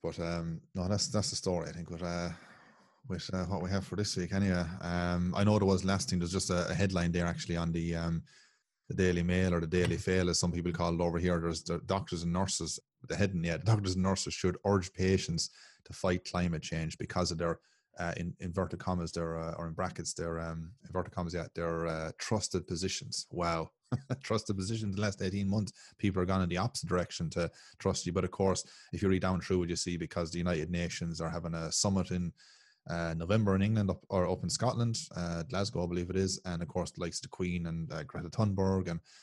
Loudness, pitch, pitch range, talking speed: -34 LUFS, 90 Hz, 85-95 Hz, 240 wpm